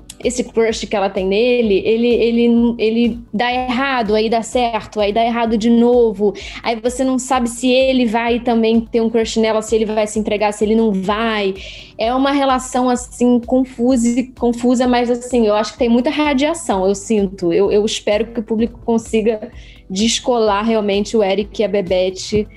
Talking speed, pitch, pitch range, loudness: 185 wpm, 230 Hz, 215-245 Hz, -16 LUFS